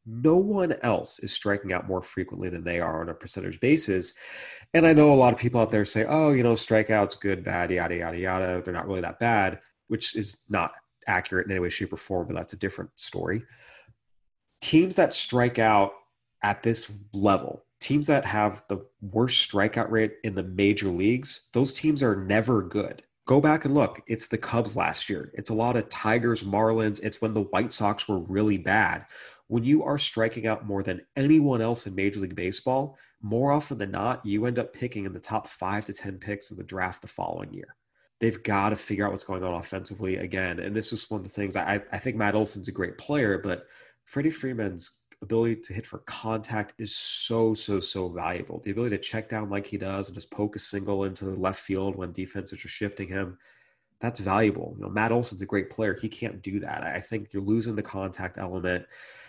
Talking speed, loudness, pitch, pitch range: 215 wpm, -26 LUFS, 105 Hz, 95-115 Hz